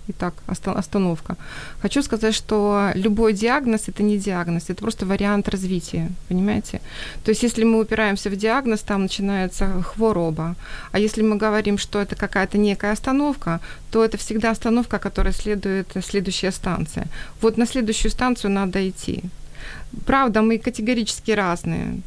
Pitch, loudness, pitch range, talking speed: 205 Hz, -22 LUFS, 190-220 Hz, 140 wpm